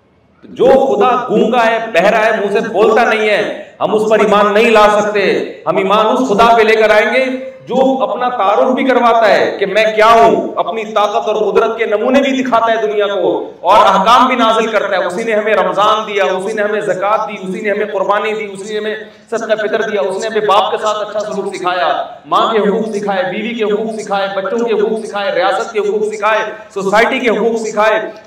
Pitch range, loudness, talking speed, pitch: 205-230 Hz, -12 LUFS, 220 wpm, 215 Hz